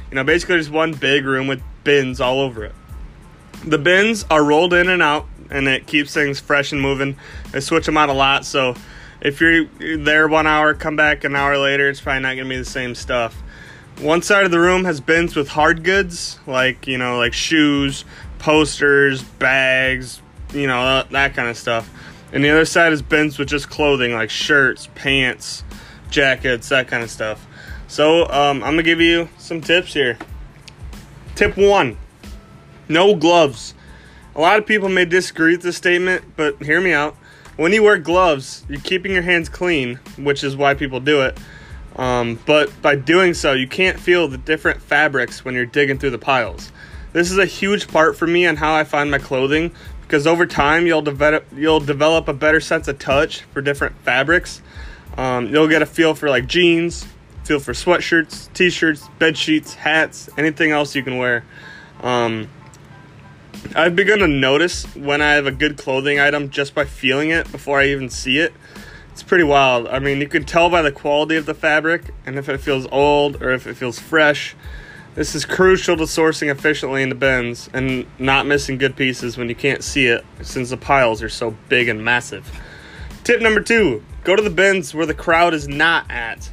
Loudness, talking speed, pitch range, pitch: -16 LUFS, 195 wpm, 135-165 Hz, 145 Hz